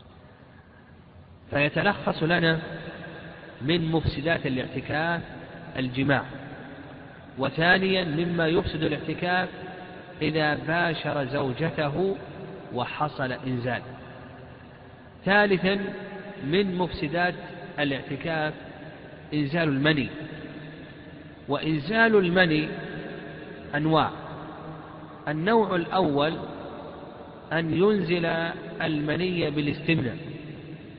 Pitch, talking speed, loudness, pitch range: 155 Hz, 60 wpm, -26 LUFS, 145-175 Hz